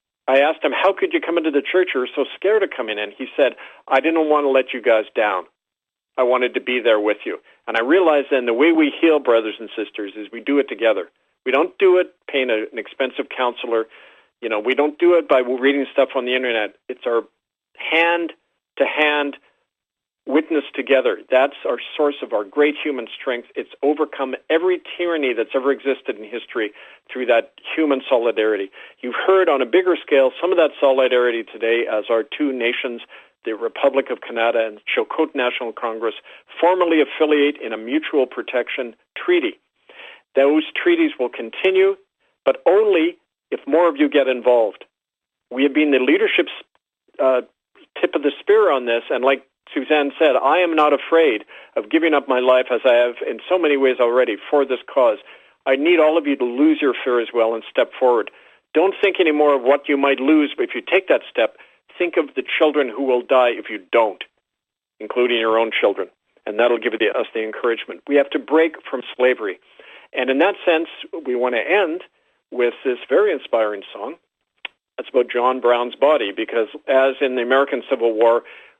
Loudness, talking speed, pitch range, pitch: -19 LUFS, 195 wpm, 125-170 Hz, 140 Hz